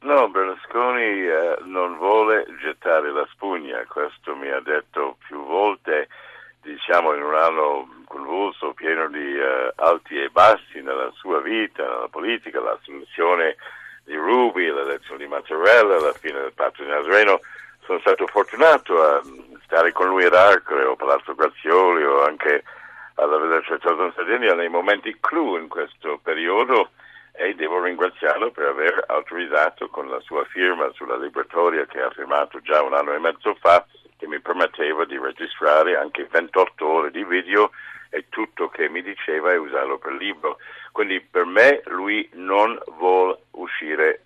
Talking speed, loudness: 155 wpm, -20 LUFS